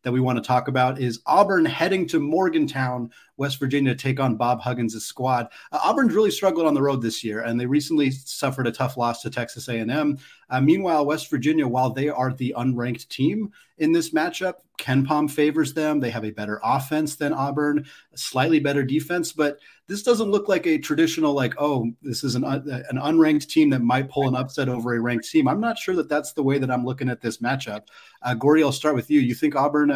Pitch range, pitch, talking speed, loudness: 125-155 Hz, 140 Hz, 225 wpm, -23 LUFS